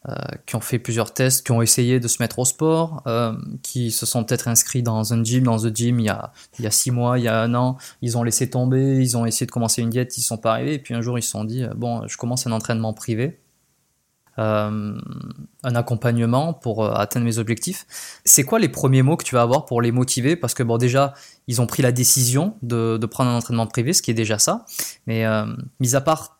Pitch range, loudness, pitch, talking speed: 115-130 Hz, -20 LUFS, 120 Hz, 260 wpm